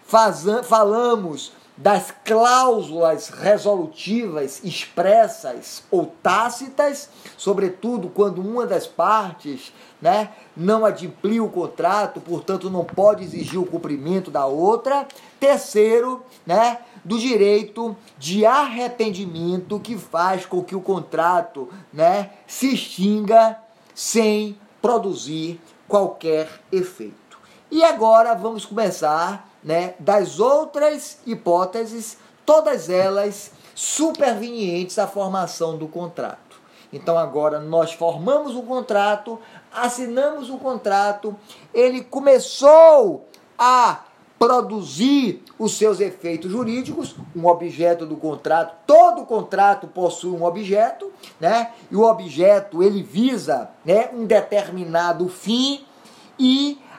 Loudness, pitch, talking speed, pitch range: -19 LUFS, 210 Hz, 105 wpm, 180-245 Hz